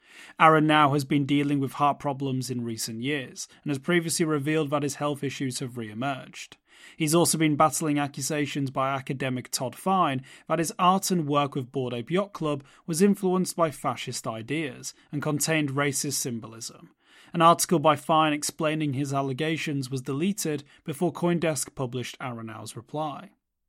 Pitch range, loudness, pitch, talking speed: 135-160 Hz, -26 LUFS, 145 Hz, 160 wpm